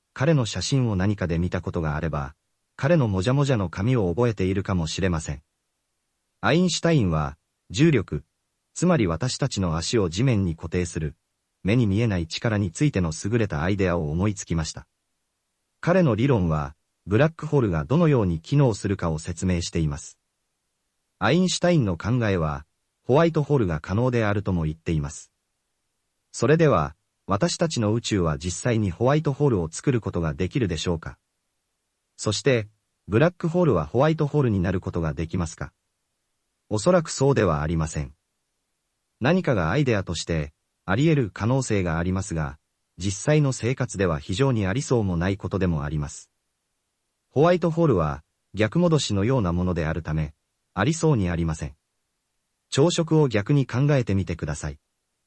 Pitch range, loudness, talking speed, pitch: 85-130 Hz, -24 LUFS, 355 characters per minute, 100 Hz